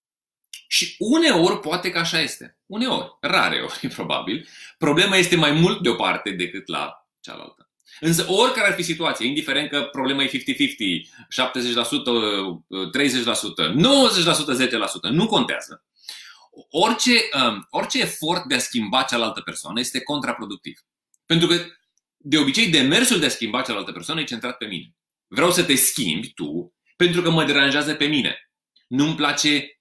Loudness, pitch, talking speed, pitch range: -20 LUFS, 160 Hz, 145 wpm, 135-190 Hz